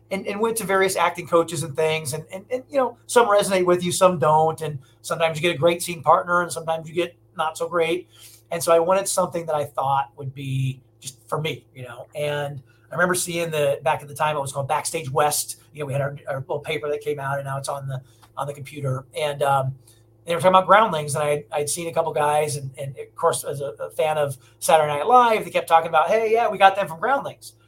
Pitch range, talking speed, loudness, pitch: 140-175 Hz, 260 wpm, -22 LUFS, 155 Hz